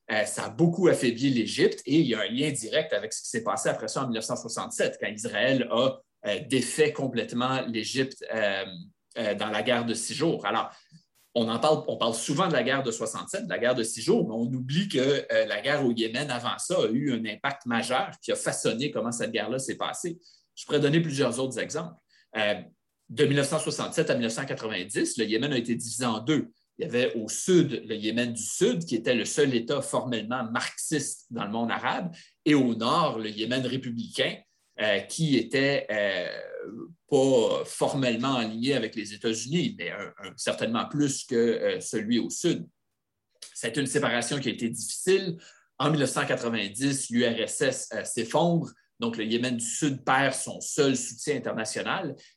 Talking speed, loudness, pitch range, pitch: 190 wpm, -27 LUFS, 115-150 Hz, 130 Hz